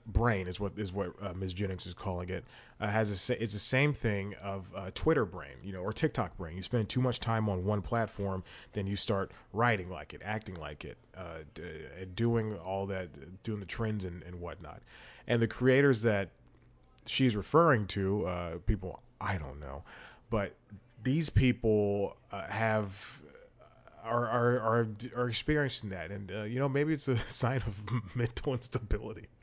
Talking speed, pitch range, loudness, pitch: 180 wpm, 95-120 Hz, -33 LUFS, 105 Hz